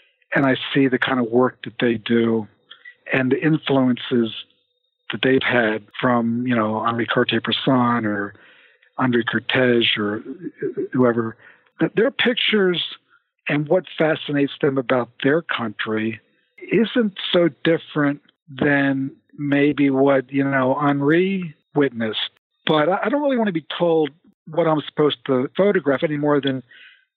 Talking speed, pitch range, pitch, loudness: 135 wpm, 120-170 Hz, 140 Hz, -20 LUFS